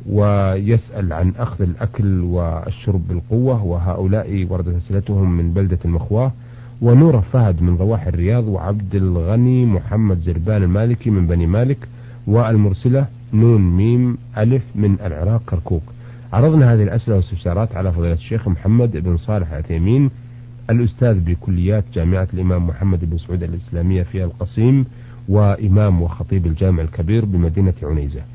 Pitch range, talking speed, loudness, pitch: 90-115 Hz, 125 wpm, -17 LUFS, 100 Hz